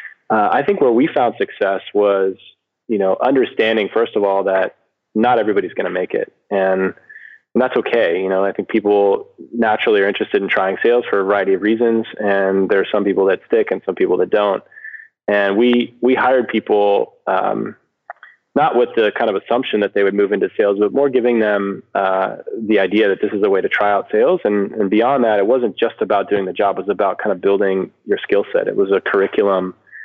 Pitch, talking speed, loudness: 105 Hz, 220 wpm, -17 LUFS